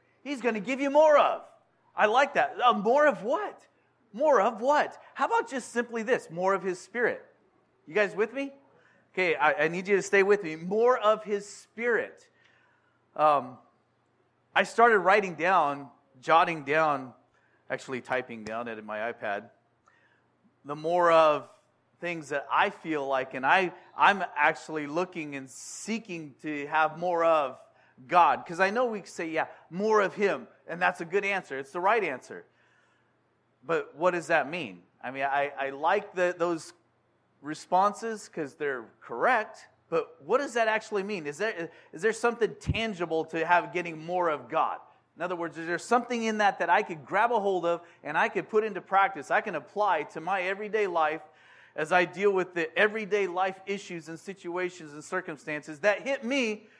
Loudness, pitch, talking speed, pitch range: -28 LUFS, 185 Hz, 180 wpm, 160-215 Hz